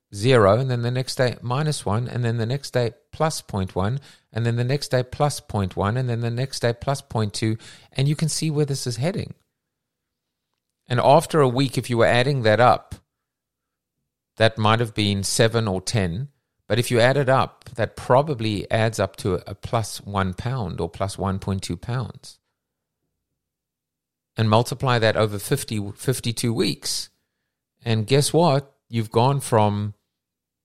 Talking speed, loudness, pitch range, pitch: 175 wpm, -22 LUFS, 105-135 Hz, 115 Hz